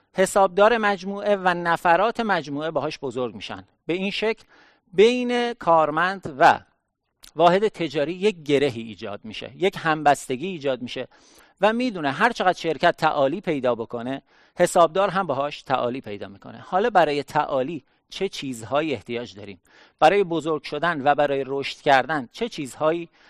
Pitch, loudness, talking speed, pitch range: 160 Hz, -22 LUFS, 140 wpm, 135-195 Hz